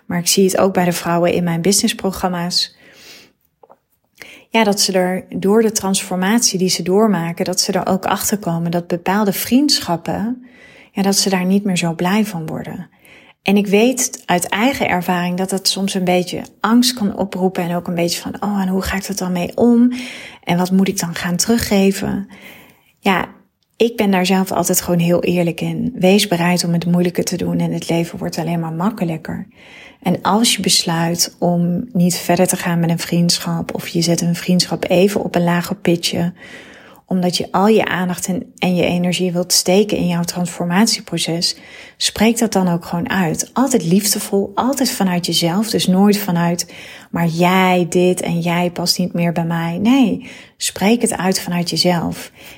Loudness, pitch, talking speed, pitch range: -16 LUFS, 185 Hz, 185 wpm, 175-205 Hz